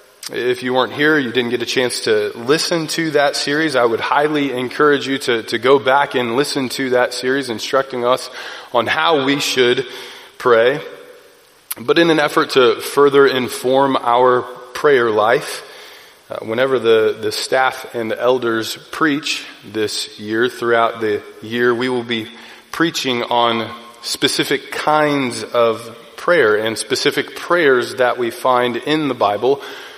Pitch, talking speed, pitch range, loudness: 135 Hz, 155 wpm, 120-170 Hz, -16 LUFS